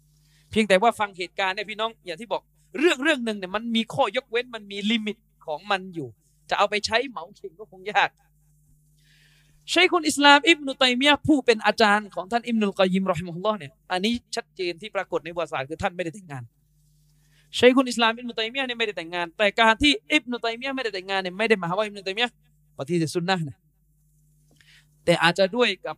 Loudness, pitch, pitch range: -23 LUFS, 195 Hz, 155-230 Hz